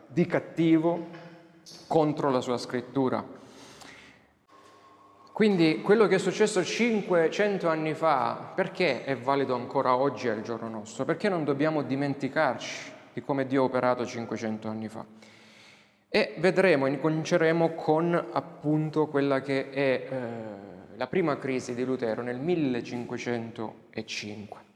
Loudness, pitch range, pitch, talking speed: -27 LUFS, 120-165 Hz, 140 Hz, 120 wpm